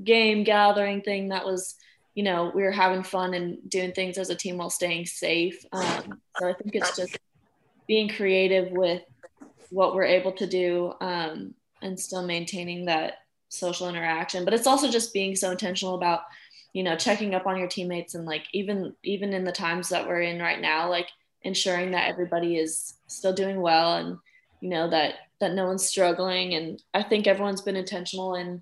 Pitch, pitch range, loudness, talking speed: 185 Hz, 175-195 Hz, -26 LUFS, 195 wpm